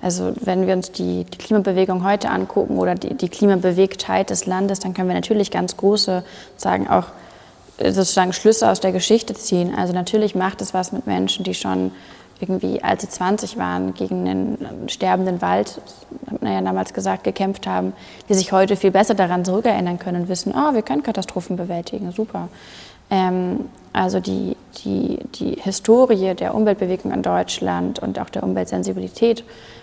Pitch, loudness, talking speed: 185 Hz, -20 LUFS, 165 wpm